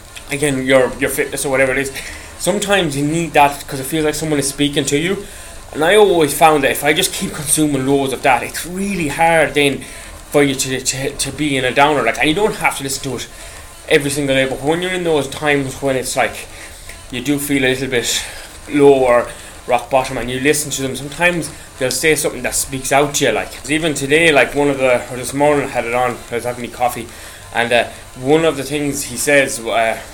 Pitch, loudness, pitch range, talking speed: 140 Hz, -16 LUFS, 125-150 Hz, 240 wpm